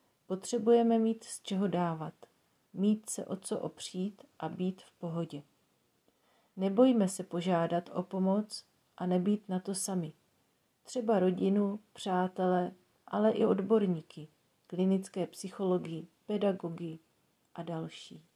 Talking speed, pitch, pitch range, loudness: 115 wpm, 190 Hz, 175-210 Hz, -33 LUFS